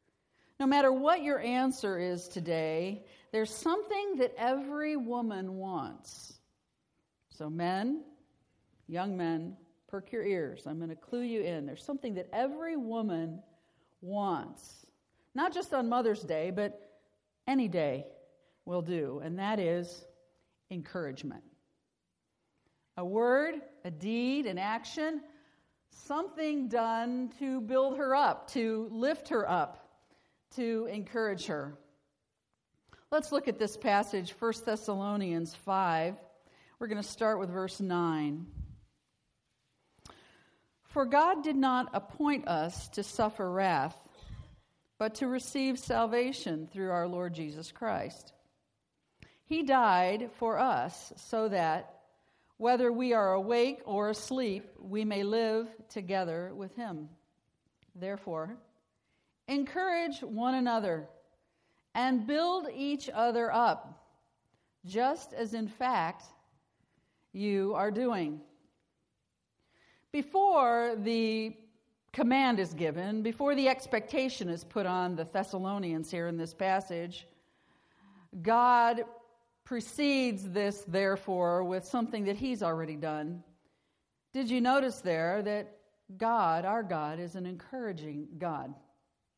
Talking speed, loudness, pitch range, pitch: 115 wpm, -33 LUFS, 175-250 Hz, 215 Hz